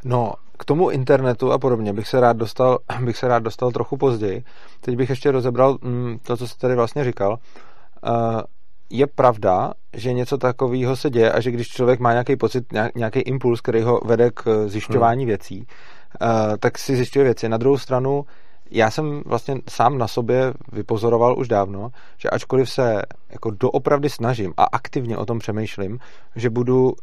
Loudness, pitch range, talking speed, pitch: -20 LUFS, 115-130 Hz, 180 wpm, 125 Hz